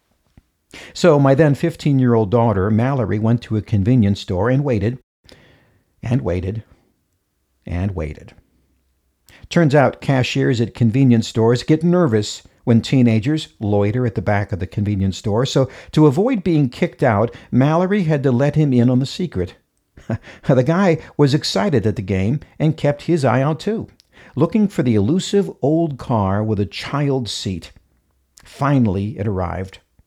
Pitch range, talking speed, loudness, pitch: 100-145 Hz, 155 wpm, -18 LUFS, 120 Hz